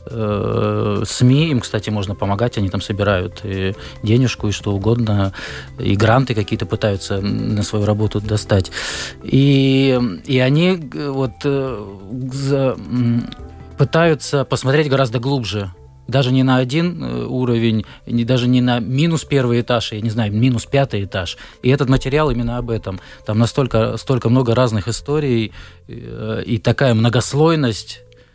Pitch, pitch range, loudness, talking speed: 120 Hz, 105-130 Hz, -18 LUFS, 130 wpm